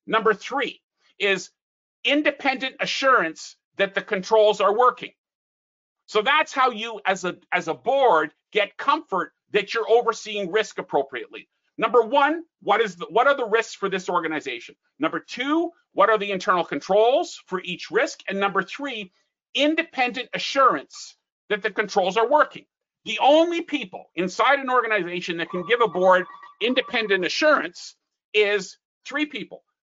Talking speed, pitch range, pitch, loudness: 150 wpm, 195-275 Hz, 225 Hz, -22 LUFS